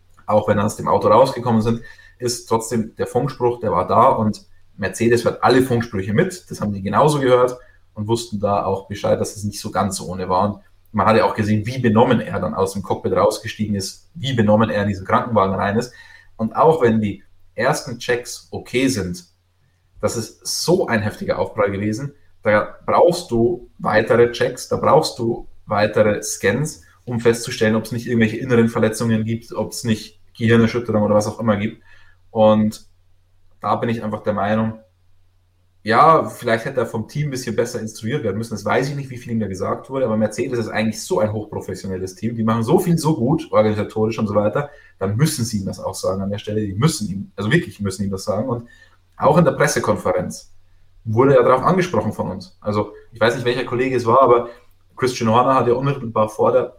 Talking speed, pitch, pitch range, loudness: 210 wpm, 110 Hz, 100-120 Hz, -19 LUFS